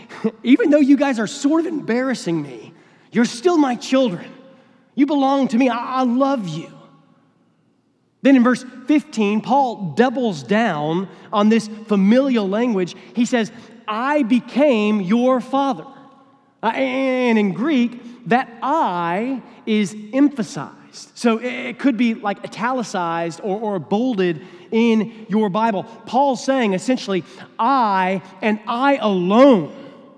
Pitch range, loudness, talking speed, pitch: 210-265 Hz, -19 LUFS, 125 wpm, 235 Hz